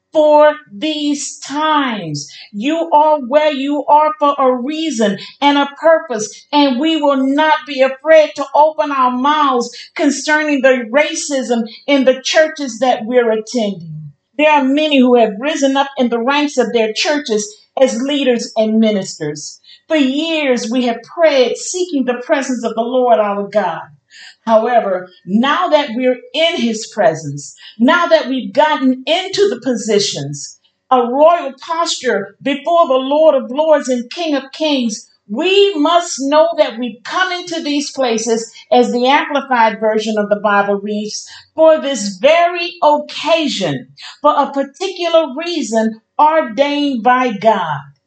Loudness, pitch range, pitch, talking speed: -14 LUFS, 225-305 Hz, 270 Hz, 145 wpm